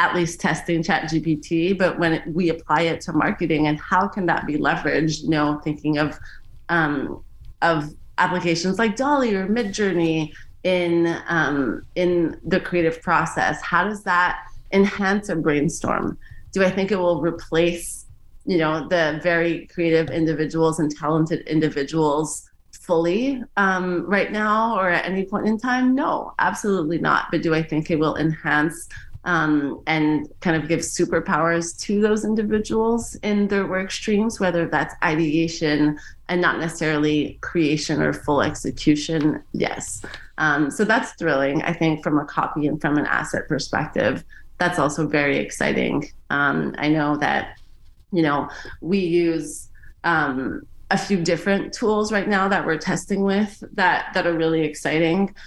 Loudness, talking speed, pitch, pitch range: -21 LUFS, 155 wpm, 165 Hz, 155-190 Hz